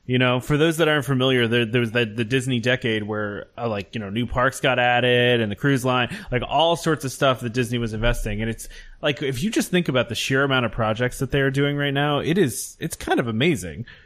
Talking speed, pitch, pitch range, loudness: 265 wpm, 125 Hz, 120-140 Hz, -22 LUFS